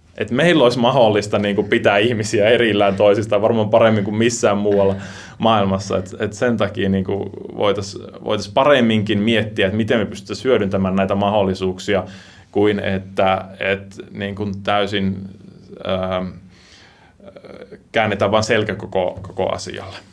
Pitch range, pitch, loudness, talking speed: 95-110 Hz, 100 Hz, -18 LUFS, 125 wpm